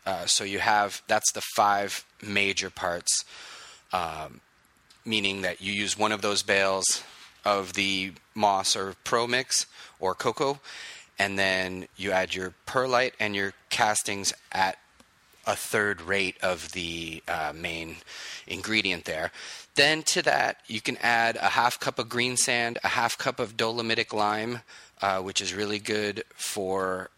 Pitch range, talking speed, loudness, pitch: 95-110 Hz, 150 wpm, -26 LUFS, 100 Hz